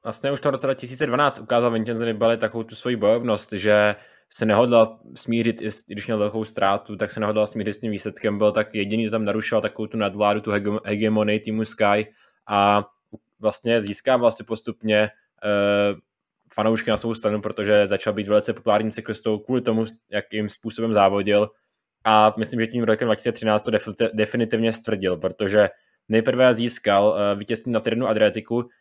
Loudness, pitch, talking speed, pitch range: -22 LUFS, 110 Hz, 165 wpm, 105-115 Hz